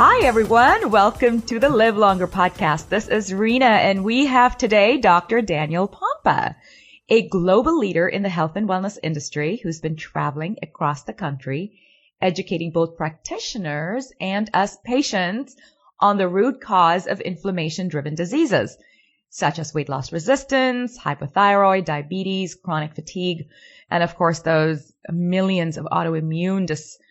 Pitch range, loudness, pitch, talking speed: 160-215 Hz, -20 LUFS, 185 Hz, 140 wpm